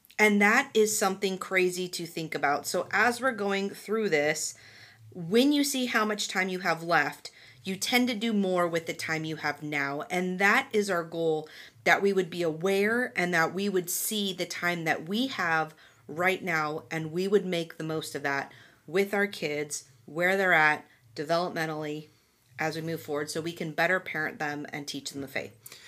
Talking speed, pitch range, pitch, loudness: 200 wpm, 155-195 Hz, 170 Hz, -28 LUFS